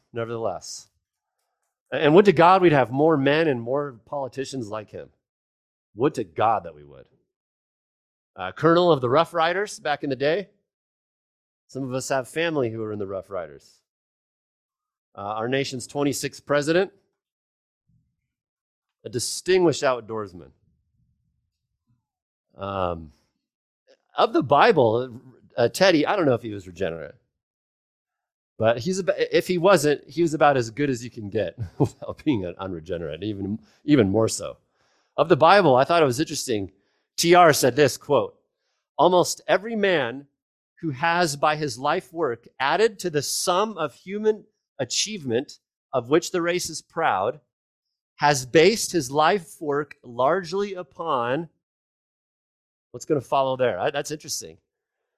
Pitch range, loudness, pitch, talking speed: 120-175 Hz, -22 LUFS, 145 Hz, 145 wpm